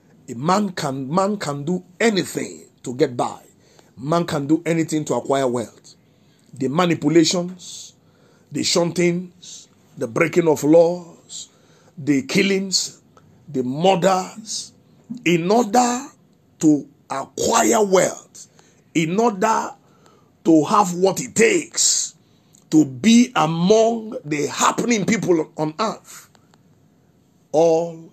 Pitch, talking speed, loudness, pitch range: 175 Hz, 105 wpm, -19 LUFS, 155-195 Hz